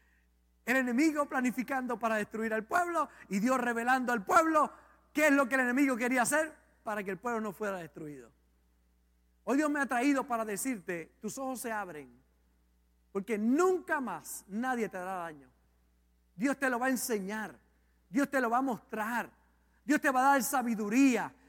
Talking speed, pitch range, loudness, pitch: 175 wpm, 175-265 Hz, -31 LUFS, 235 Hz